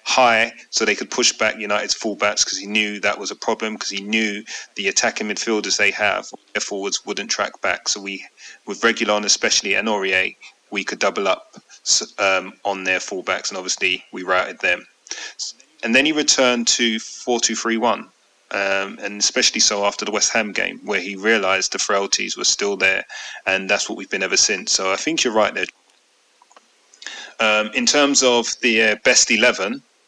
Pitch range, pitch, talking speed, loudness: 100-115 Hz, 105 Hz, 185 wpm, -18 LUFS